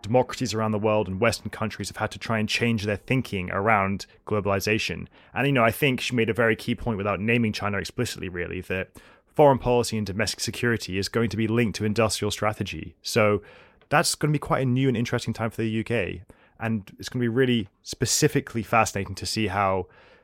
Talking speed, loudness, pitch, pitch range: 215 wpm, -25 LUFS, 110 Hz, 100-120 Hz